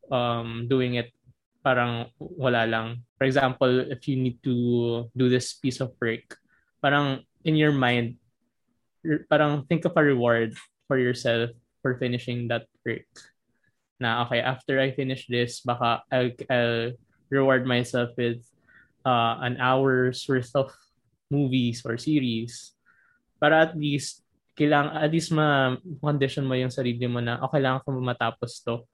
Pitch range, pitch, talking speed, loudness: 120-135 Hz, 125 Hz, 140 wpm, -25 LUFS